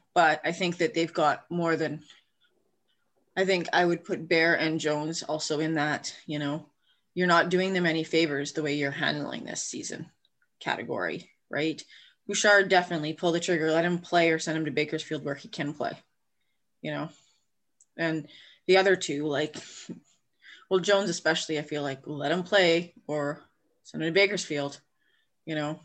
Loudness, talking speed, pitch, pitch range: -27 LUFS, 175 wpm, 160 Hz, 150-175 Hz